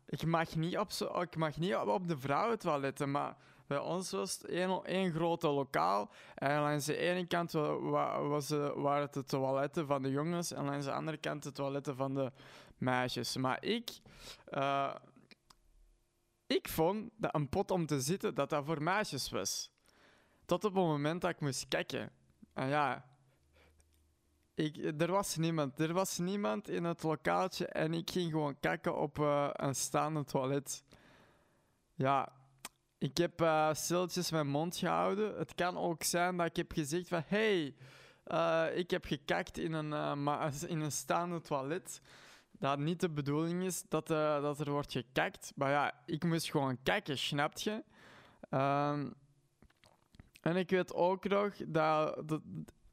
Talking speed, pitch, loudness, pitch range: 165 wpm, 155 Hz, -36 LUFS, 140-175 Hz